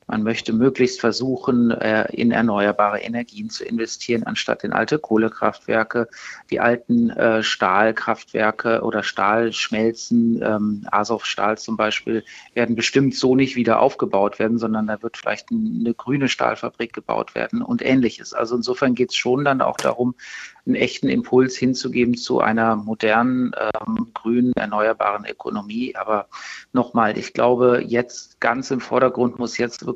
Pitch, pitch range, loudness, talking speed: 120 Hz, 110-125 Hz, -20 LUFS, 135 wpm